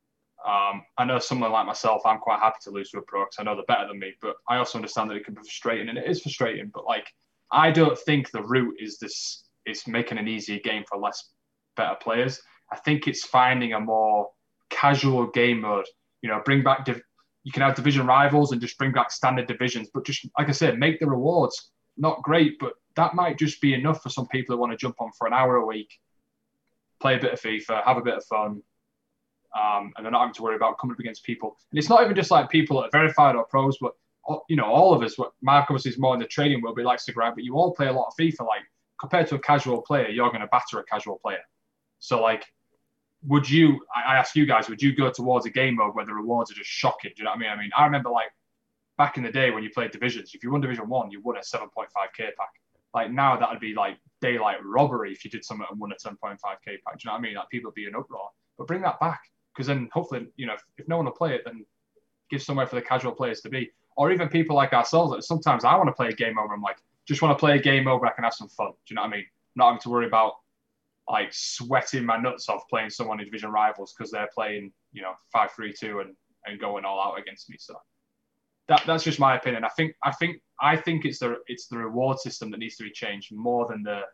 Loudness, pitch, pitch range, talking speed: -24 LUFS, 125 Hz, 110-145 Hz, 265 wpm